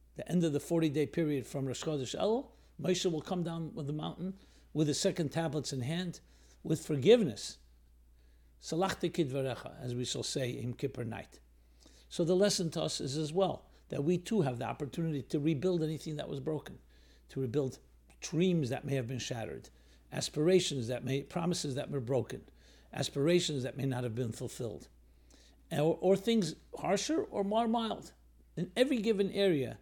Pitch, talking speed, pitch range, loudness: 145 Hz, 175 wpm, 125-175 Hz, -34 LUFS